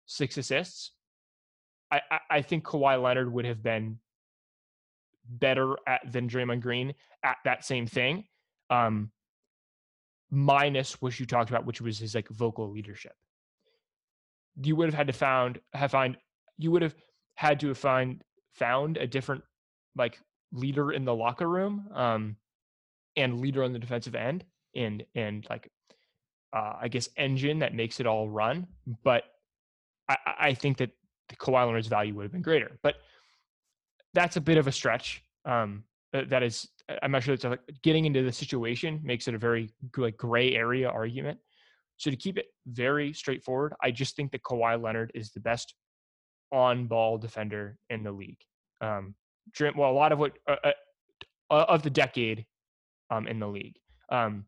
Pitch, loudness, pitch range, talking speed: 125 Hz, -29 LUFS, 115-145 Hz, 165 wpm